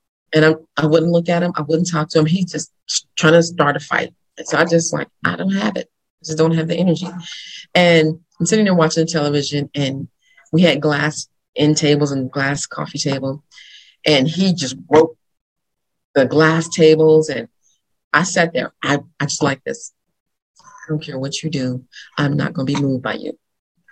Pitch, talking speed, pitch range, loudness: 155 Hz, 205 wpm, 145-170 Hz, -17 LUFS